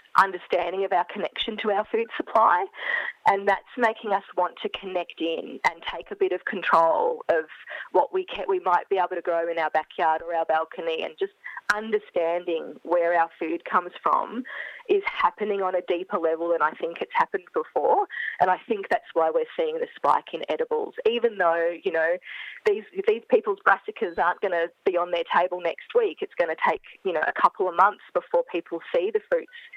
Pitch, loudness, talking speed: 205 Hz, -25 LUFS, 205 wpm